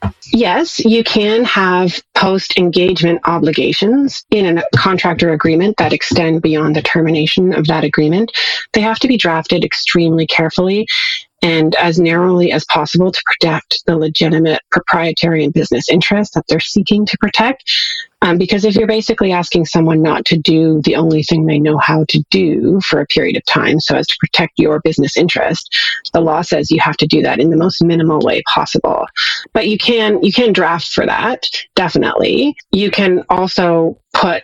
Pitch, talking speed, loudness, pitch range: 175 Hz, 175 wpm, -12 LUFS, 160-210 Hz